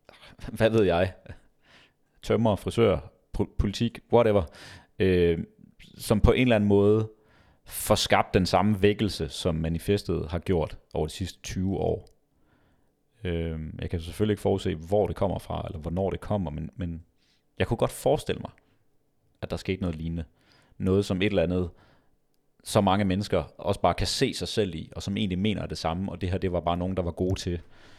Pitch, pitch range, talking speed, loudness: 95 Hz, 85-105 Hz, 185 wpm, -27 LUFS